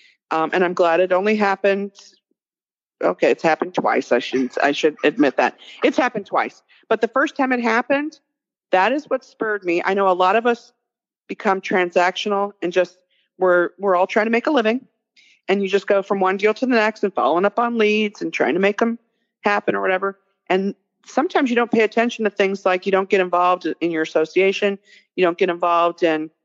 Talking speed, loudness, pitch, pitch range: 210 wpm, -19 LUFS, 200 Hz, 185-230 Hz